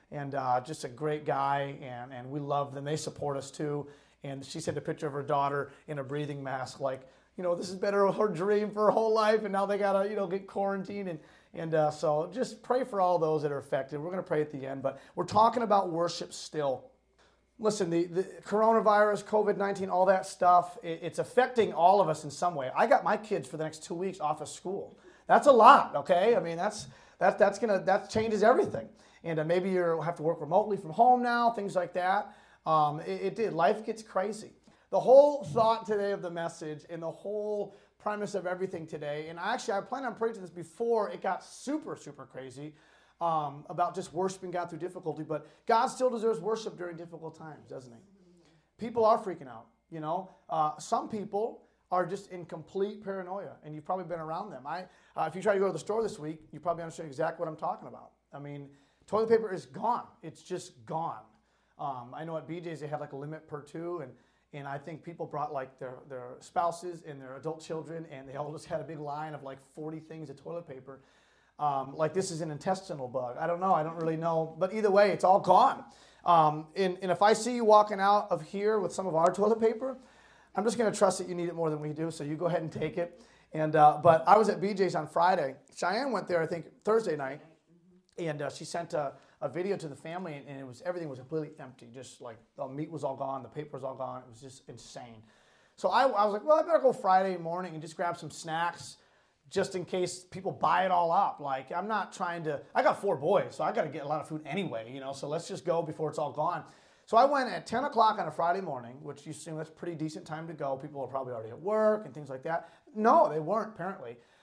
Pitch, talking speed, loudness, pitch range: 170 Hz, 240 wpm, -30 LUFS, 150-195 Hz